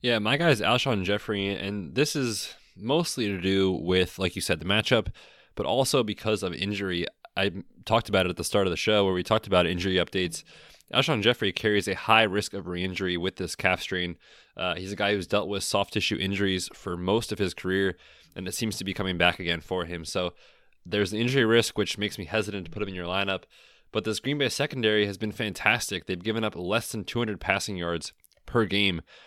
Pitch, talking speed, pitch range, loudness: 100 Hz, 230 wpm, 90-110 Hz, -27 LUFS